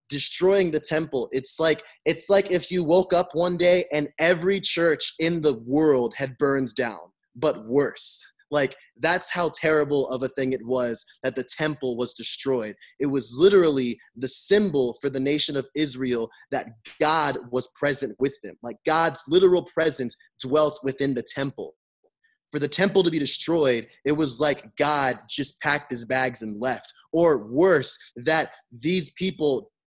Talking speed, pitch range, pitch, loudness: 165 wpm, 130-165 Hz, 145 Hz, -23 LUFS